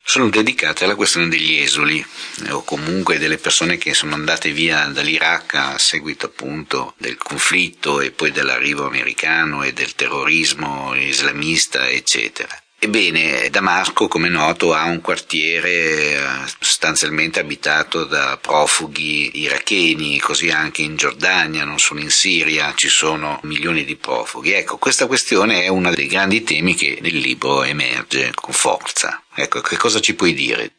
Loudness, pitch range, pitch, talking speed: -16 LUFS, 75-85 Hz, 80 Hz, 145 wpm